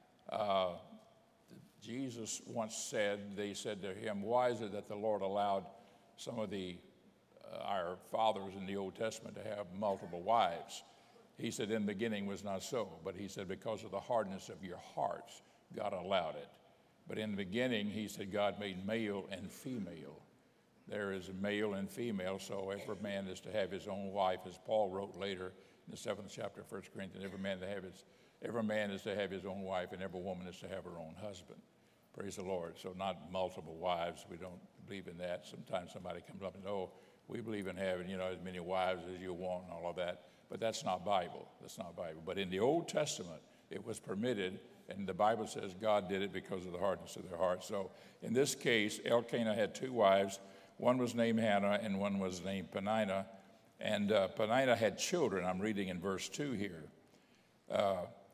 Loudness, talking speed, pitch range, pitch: -39 LUFS, 205 wpm, 95-105 Hz, 100 Hz